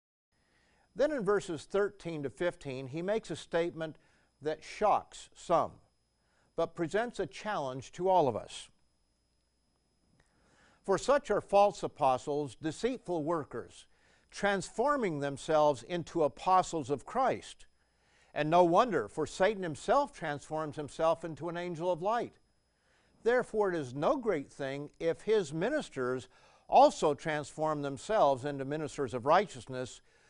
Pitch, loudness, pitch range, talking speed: 160 Hz, -32 LUFS, 140-185 Hz, 125 wpm